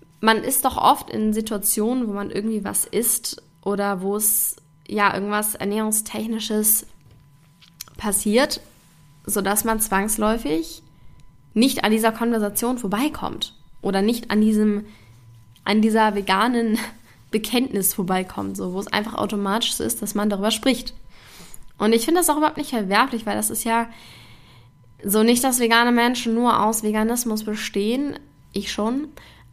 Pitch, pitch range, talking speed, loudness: 215 Hz, 195-230 Hz, 140 wpm, -21 LUFS